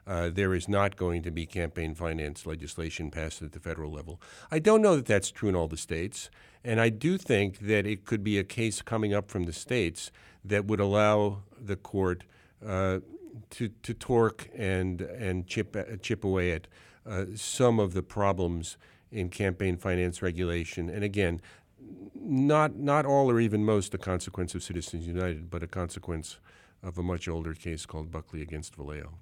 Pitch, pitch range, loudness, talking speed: 95 Hz, 85-105 Hz, -30 LUFS, 185 wpm